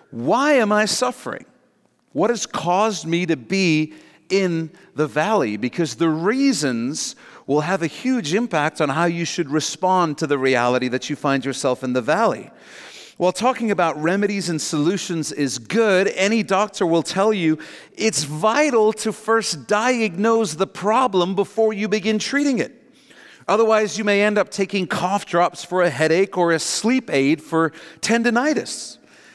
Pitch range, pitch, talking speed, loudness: 160-215 Hz, 185 Hz, 160 wpm, -20 LUFS